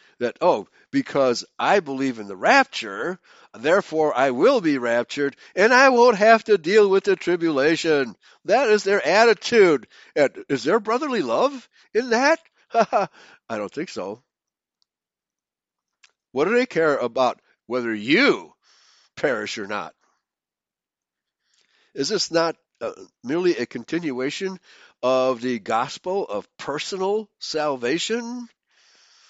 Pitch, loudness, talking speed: 200 Hz, -21 LUFS, 125 wpm